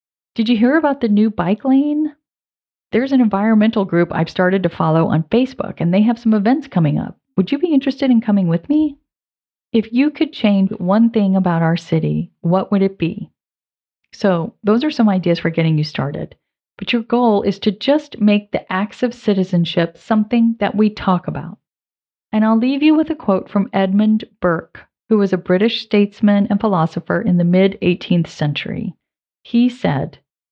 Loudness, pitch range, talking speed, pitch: -17 LUFS, 180-235 Hz, 185 wpm, 205 Hz